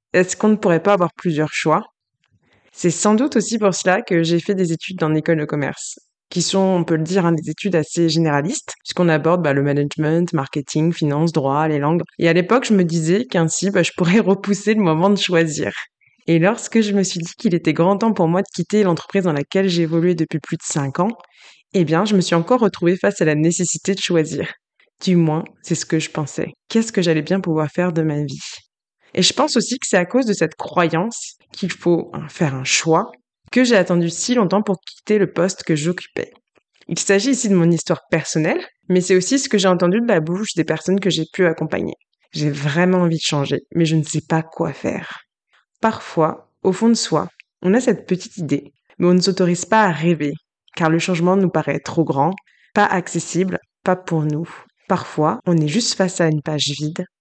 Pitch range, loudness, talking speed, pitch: 160-195 Hz, -18 LUFS, 220 wpm, 175 Hz